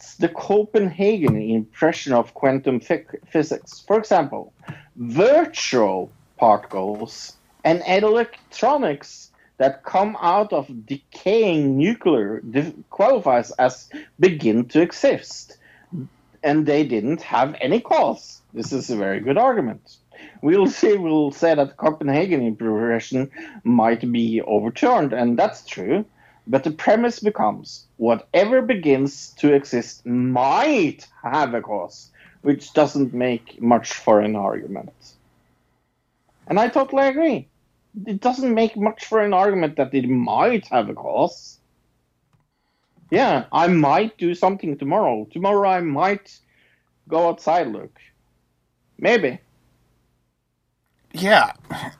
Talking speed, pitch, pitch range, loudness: 115 wpm, 140 Hz, 115-190 Hz, -20 LUFS